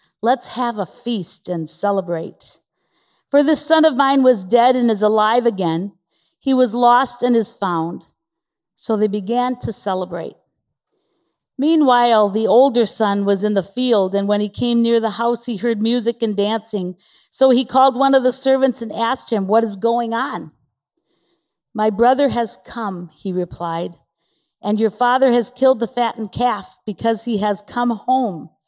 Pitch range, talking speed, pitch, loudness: 205-250 Hz, 170 wpm, 230 Hz, -18 LUFS